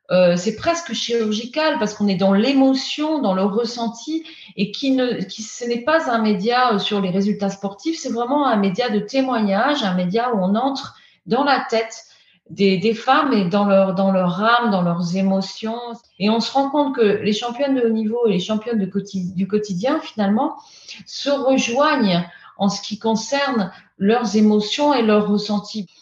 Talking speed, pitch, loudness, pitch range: 185 wpm, 225 Hz, -19 LUFS, 200-260 Hz